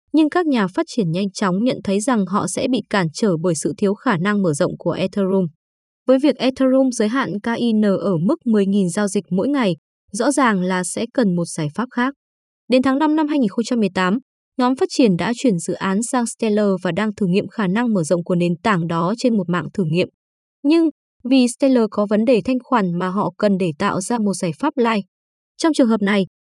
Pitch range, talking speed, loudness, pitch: 190-255 Hz, 225 wpm, -19 LUFS, 210 Hz